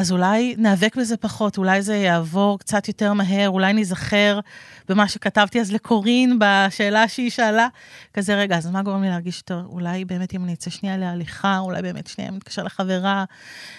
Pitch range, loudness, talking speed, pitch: 185-215 Hz, -20 LUFS, 185 wpm, 200 Hz